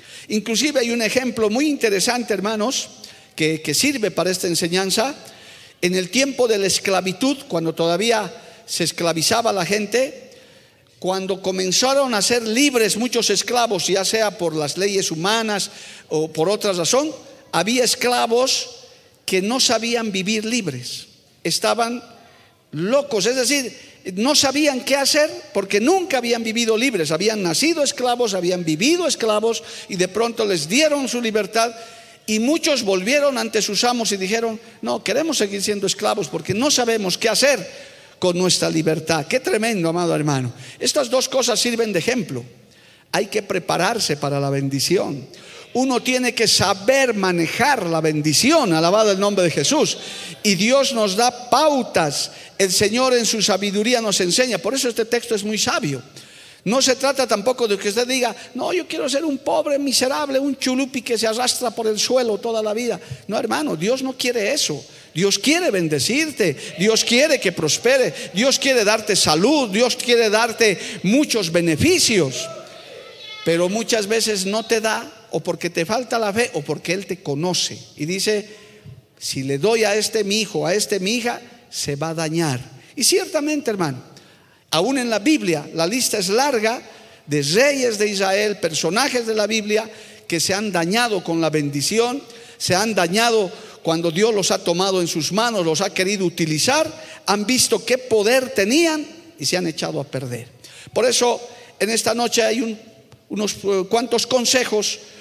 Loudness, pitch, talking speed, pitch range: -19 LUFS, 220 Hz, 165 wpm, 180-245 Hz